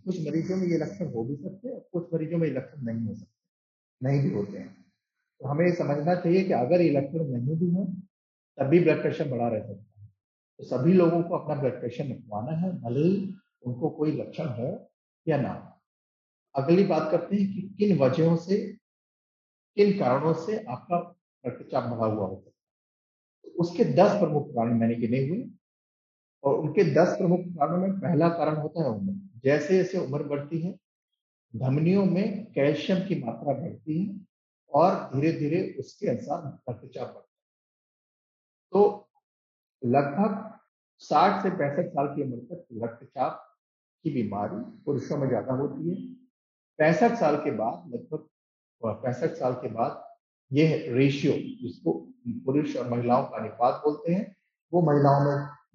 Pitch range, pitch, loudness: 140-185 Hz, 160 Hz, -27 LUFS